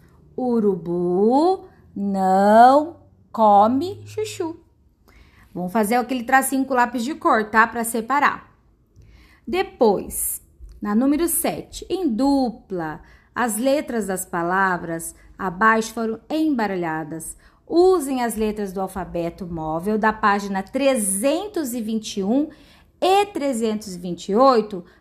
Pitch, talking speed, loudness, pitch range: 225 Hz, 95 wpm, -20 LUFS, 195-275 Hz